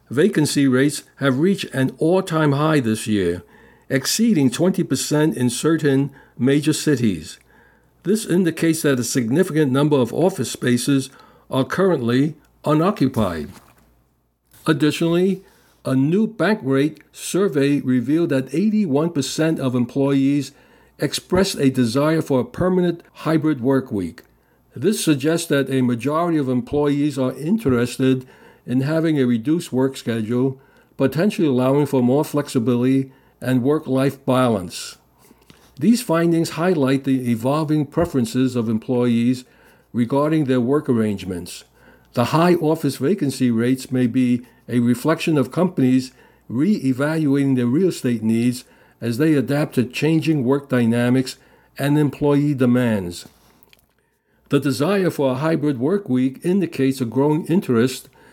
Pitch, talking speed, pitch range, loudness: 140 Hz, 125 wpm, 125-155 Hz, -19 LUFS